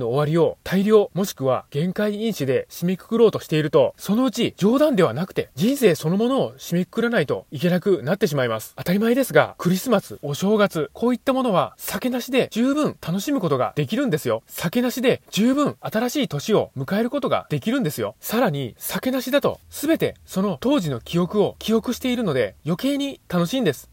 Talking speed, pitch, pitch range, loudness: 415 characters per minute, 210 Hz, 170-250 Hz, -22 LUFS